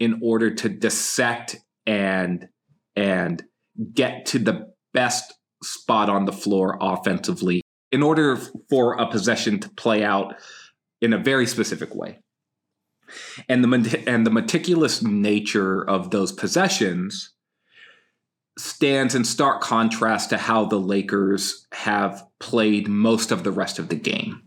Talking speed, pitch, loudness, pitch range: 130 wpm, 115 Hz, -22 LUFS, 100-125 Hz